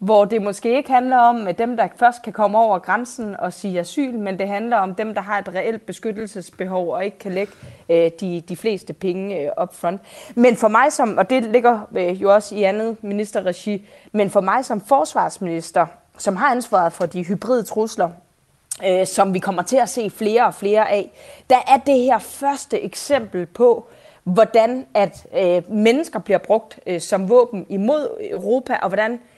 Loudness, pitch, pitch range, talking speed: -19 LUFS, 210 Hz, 185-240 Hz, 180 wpm